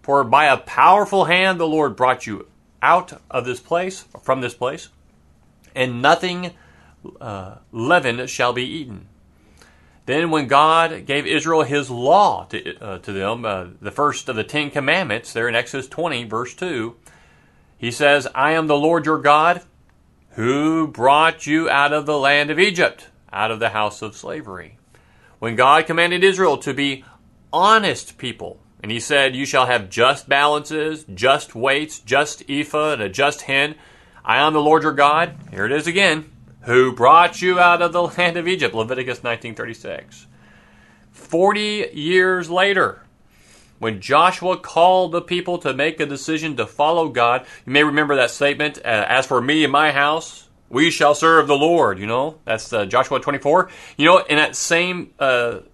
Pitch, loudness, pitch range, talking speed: 145 Hz, -17 LUFS, 125-160 Hz, 170 wpm